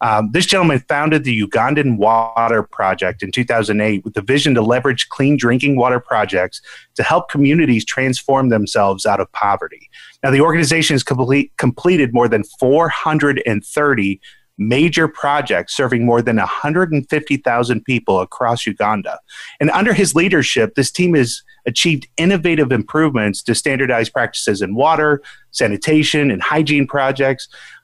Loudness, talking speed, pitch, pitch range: -15 LUFS, 140 wpm, 135 Hz, 115-150 Hz